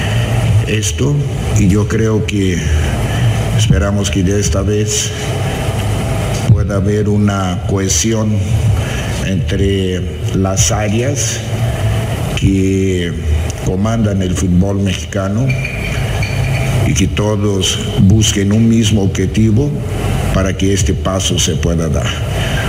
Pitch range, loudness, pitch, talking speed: 95-115 Hz, -14 LUFS, 105 Hz, 95 wpm